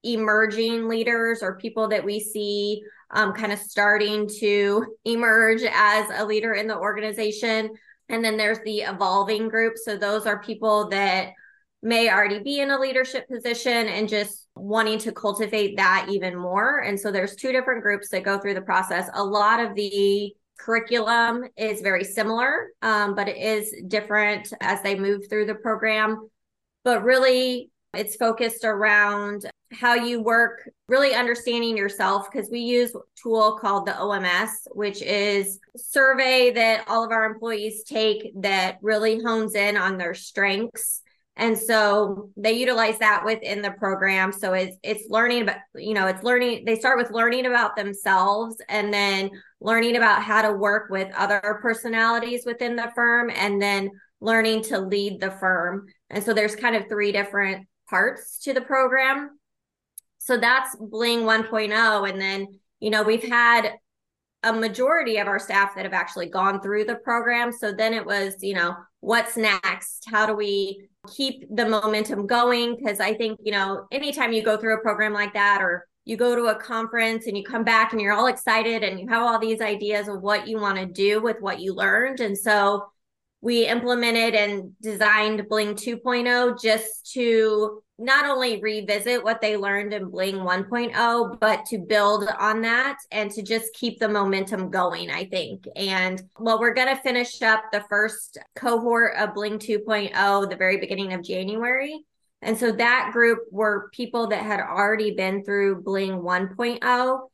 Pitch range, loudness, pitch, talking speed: 205-230 Hz, -22 LUFS, 215 Hz, 175 wpm